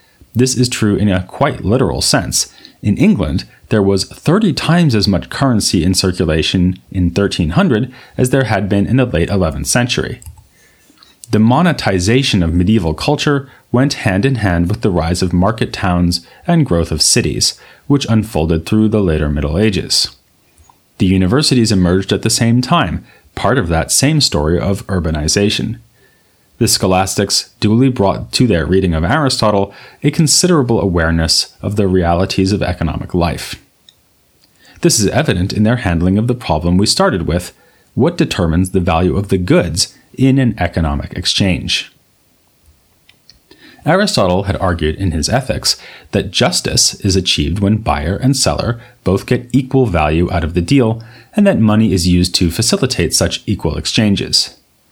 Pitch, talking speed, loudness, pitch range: 100 Hz, 155 wpm, -14 LUFS, 90-125 Hz